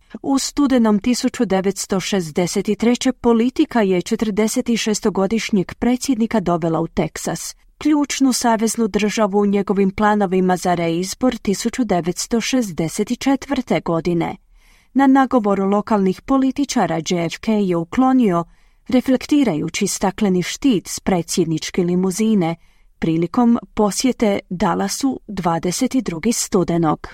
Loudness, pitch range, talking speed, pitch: -18 LUFS, 185-245 Hz, 85 wpm, 210 Hz